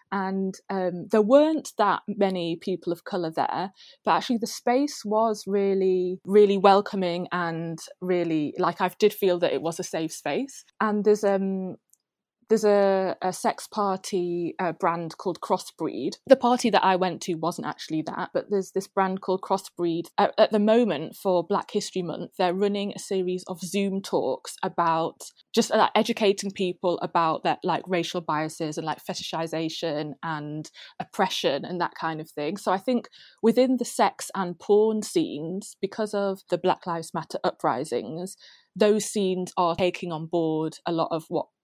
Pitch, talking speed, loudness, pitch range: 185 Hz, 170 wpm, -25 LUFS, 170-205 Hz